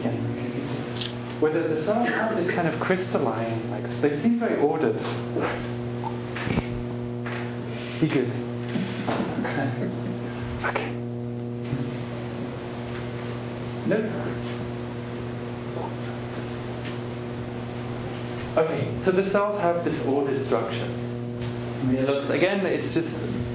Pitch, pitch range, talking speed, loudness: 120 Hz, 120-125 Hz, 85 wpm, -27 LUFS